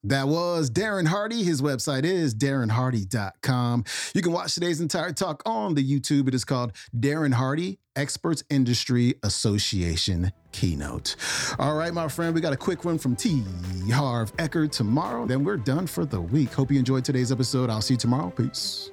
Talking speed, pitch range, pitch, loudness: 180 wpm, 125-165 Hz, 140 Hz, -25 LUFS